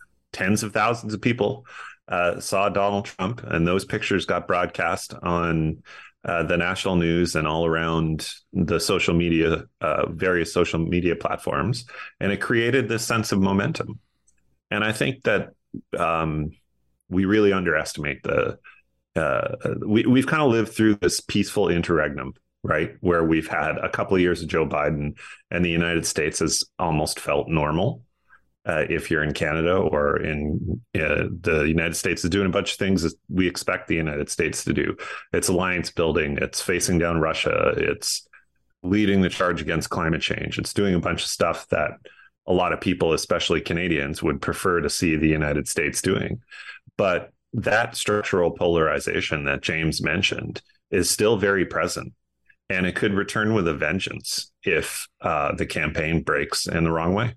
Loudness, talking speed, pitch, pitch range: -23 LUFS, 170 wpm, 85 Hz, 80-100 Hz